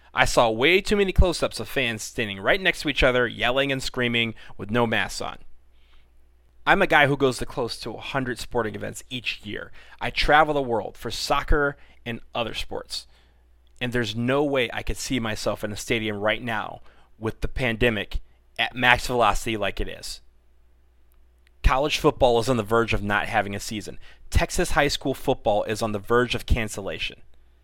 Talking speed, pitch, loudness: 190 wpm, 110 Hz, -24 LUFS